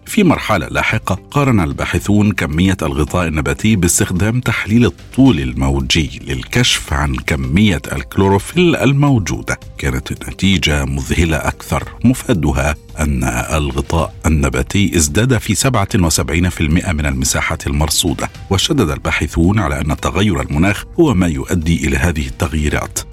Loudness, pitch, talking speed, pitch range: -15 LUFS, 85 Hz, 110 wpm, 75-105 Hz